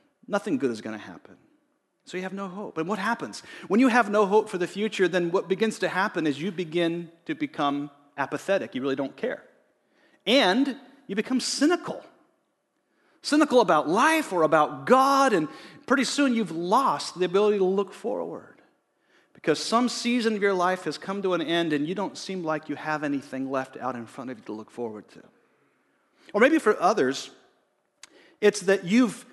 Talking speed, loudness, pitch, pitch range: 190 wpm, -25 LUFS, 190 Hz, 155-230 Hz